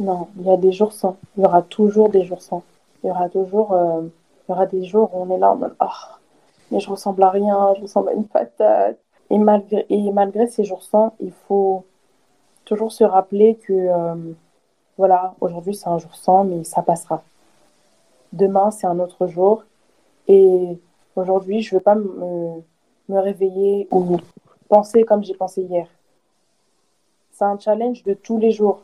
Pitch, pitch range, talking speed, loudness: 195 Hz, 180-210 Hz, 190 wpm, -18 LUFS